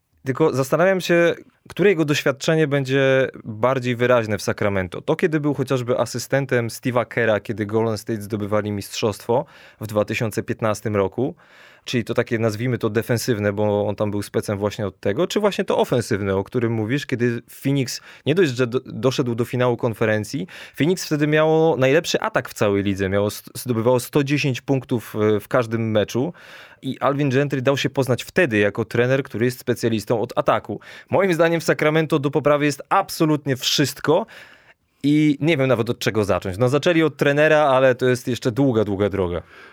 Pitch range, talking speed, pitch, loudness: 110-145 Hz, 170 wpm, 125 Hz, -21 LUFS